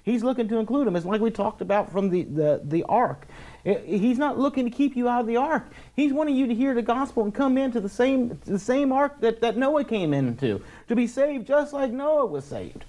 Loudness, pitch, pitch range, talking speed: -24 LUFS, 240 Hz, 205-270 Hz, 245 wpm